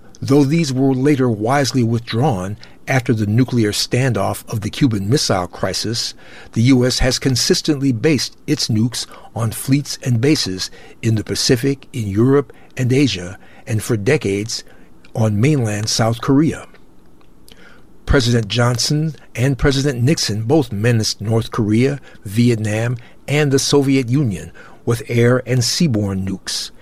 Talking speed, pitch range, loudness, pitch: 130 wpm, 110-140 Hz, -17 LUFS, 120 Hz